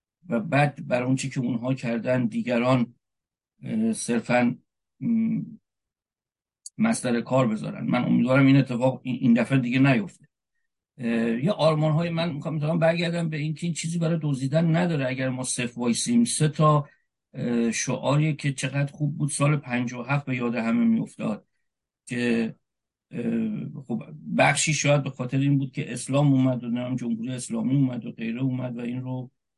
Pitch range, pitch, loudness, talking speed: 120-155 Hz, 135 Hz, -25 LUFS, 150 wpm